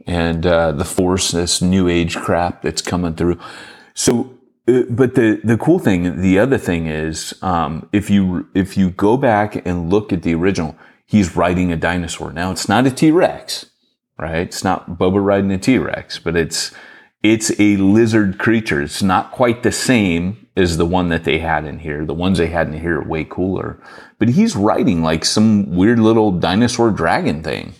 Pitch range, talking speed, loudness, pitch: 85-105 Hz, 190 wpm, -16 LUFS, 90 Hz